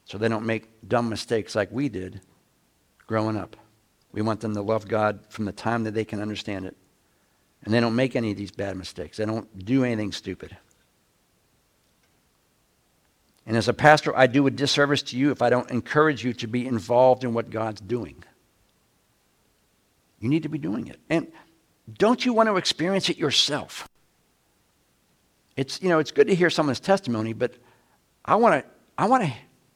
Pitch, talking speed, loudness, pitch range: 120 Hz, 185 wpm, -24 LUFS, 110-145 Hz